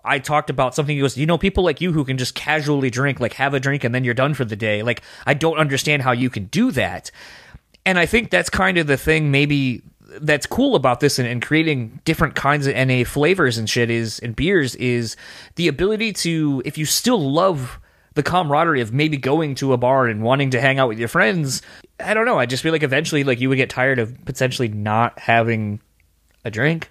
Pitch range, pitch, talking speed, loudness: 120-155 Hz, 135 Hz, 235 wpm, -19 LUFS